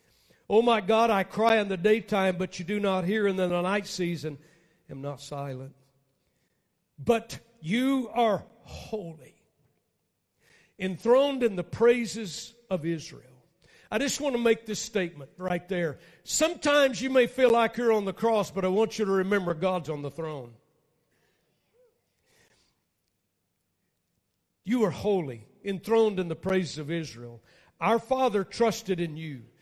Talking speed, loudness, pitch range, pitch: 150 wpm, -27 LUFS, 165-225 Hz, 190 Hz